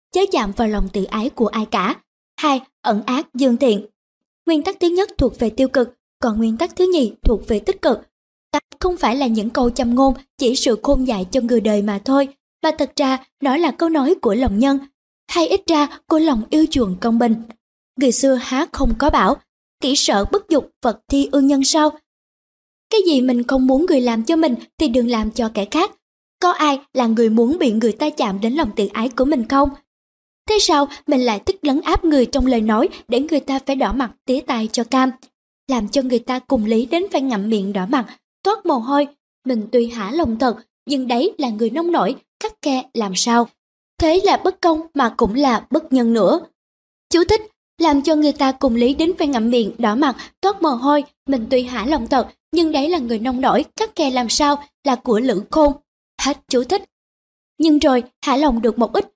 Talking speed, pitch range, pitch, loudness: 225 wpm, 240-305 Hz, 270 Hz, -18 LUFS